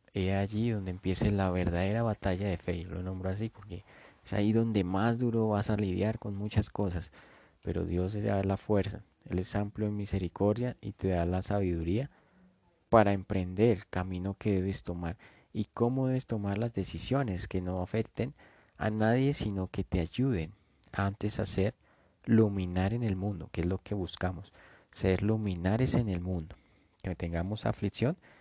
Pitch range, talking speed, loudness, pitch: 90-110 Hz, 175 wpm, -32 LUFS, 100 Hz